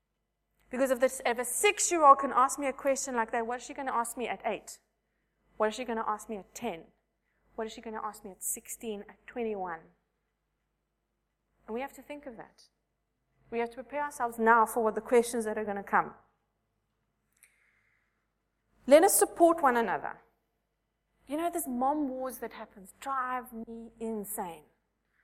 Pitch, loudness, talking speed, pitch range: 240 Hz, -29 LUFS, 190 wpm, 225-270 Hz